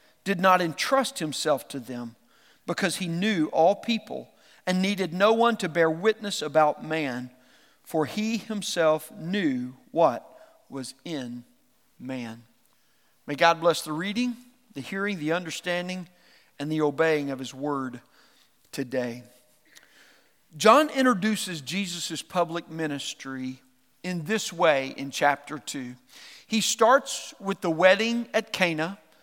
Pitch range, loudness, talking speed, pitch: 140-205 Hz, -26 LUFS, 125 wpm, 170 Hz